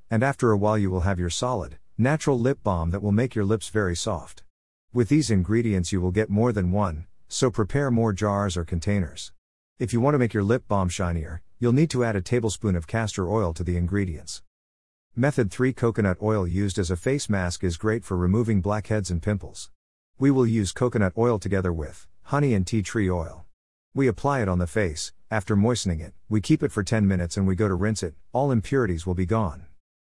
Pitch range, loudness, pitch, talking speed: 90-115 Hz, -25 LUFS, 100 Hz, 220 wpm